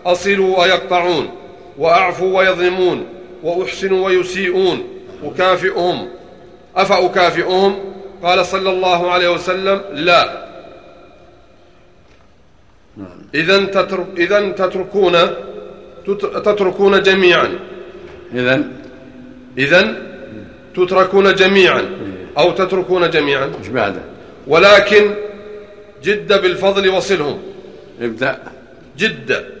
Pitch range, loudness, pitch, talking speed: 180-195 Hz, -14 LUFS, 185 Hz, 65 wpm